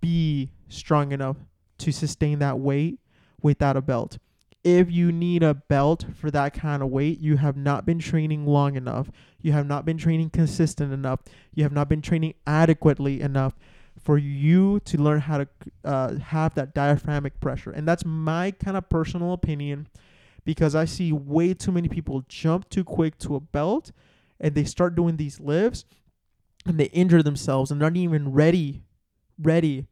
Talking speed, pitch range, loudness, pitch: 175 wpm, 140-165 Hz, -24 LUFS, 150 Hz